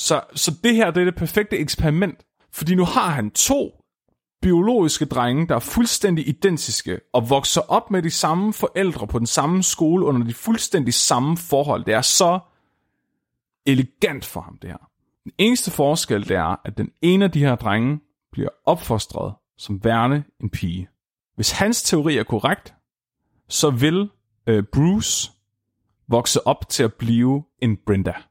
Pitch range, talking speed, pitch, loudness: 115-180 Hz, 165 wpm, 145 Hz, -20 LUFS